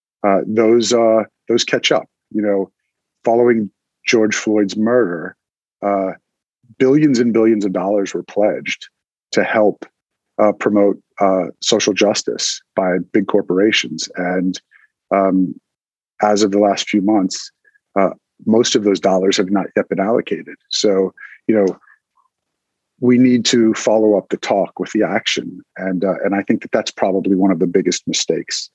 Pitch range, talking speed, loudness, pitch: 95-115 Hz, 155 wpm, -16 LUFS, 105 Hz